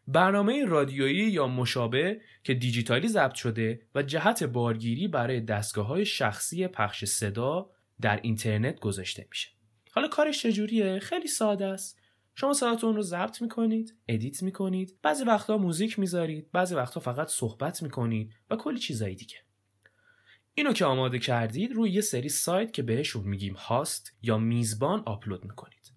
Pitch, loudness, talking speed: 140 Hz, -28 LUFS, 145 wpm